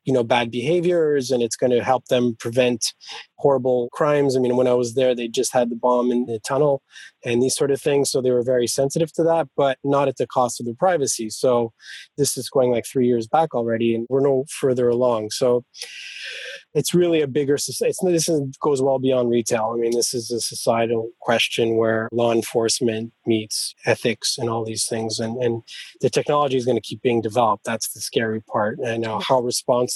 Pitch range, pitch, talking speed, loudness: 115-135 Hz, 125 Hz, 215 wpm, -21 LUFS